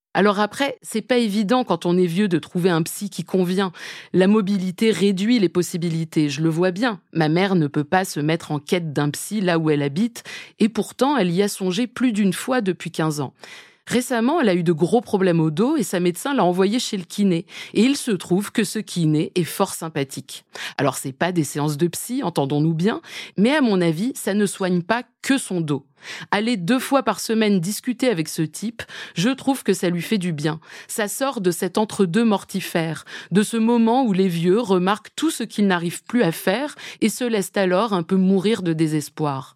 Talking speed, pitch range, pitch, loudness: 220 wpm, 170-220 Hz, 190 Hz, -21 LUFS